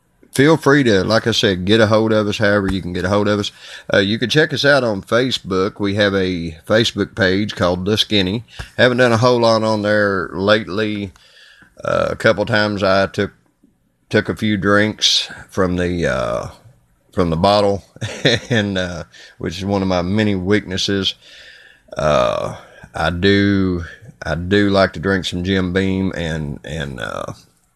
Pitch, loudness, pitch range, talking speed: 100 Hz, -17 LUFS, 90-110 Hz, 175 wpm